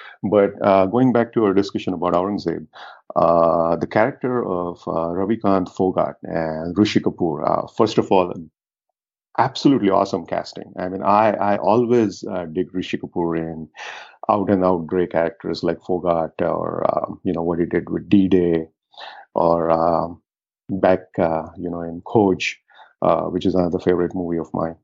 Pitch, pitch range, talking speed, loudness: 90 Hz, 85-100 Hz, 160 wpm, -20 LUFS